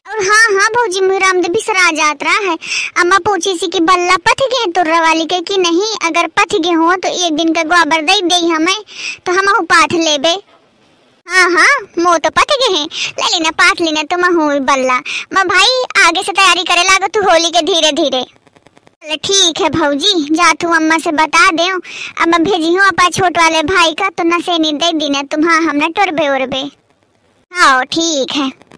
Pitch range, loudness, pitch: 320-380 Hz, -11 LUFS, 345 Hz